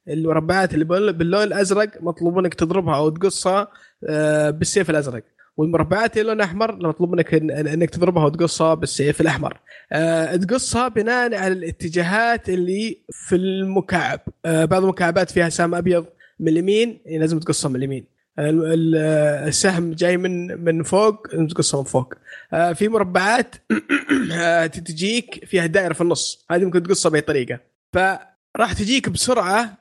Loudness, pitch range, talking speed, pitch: -19 LUFS, 160-195 Hz, 130 wpm, 175 Hz